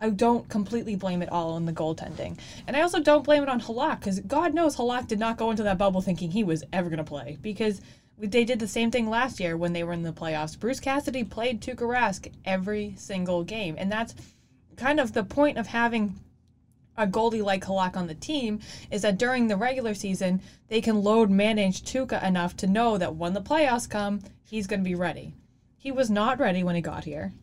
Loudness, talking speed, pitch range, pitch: -27 LUFS, 225 wpm, 185-240 Hz, 210 Hz